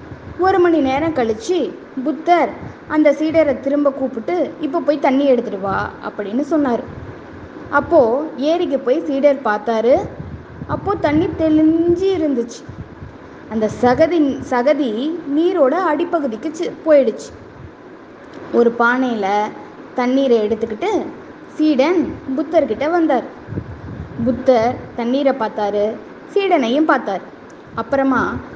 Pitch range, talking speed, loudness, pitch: 245-320 Hz, 90 wpm, -17 LUFS, 280 Hz